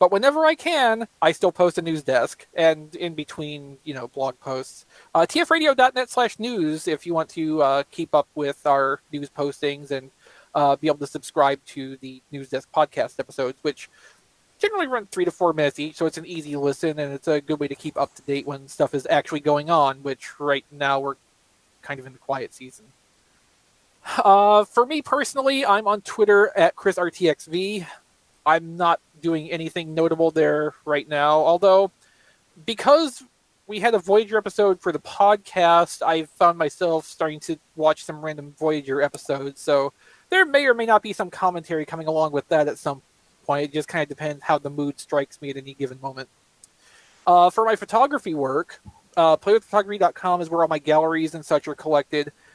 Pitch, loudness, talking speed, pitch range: 160 Hz, -22 LUFS, 190 wpm, 145-195 Hz